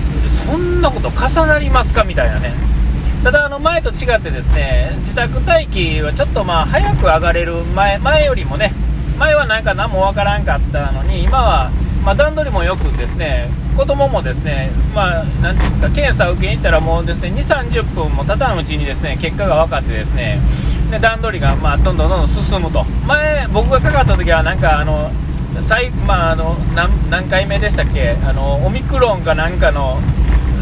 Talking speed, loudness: 365 characters per minute, -15 LUFS